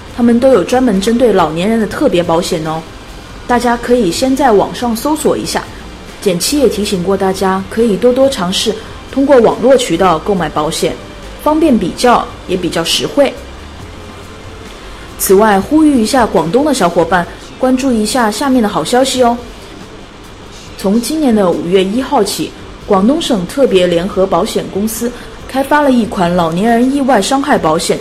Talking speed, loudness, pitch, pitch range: 255 characters per minute, -12 LUFS, 215 Hz, 175-255 Hz